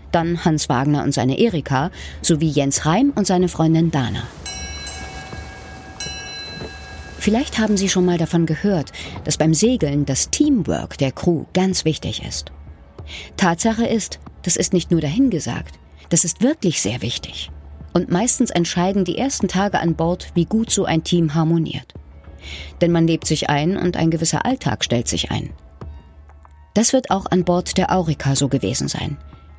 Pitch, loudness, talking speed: 160 Hz, -19 LUFS, 160 wpm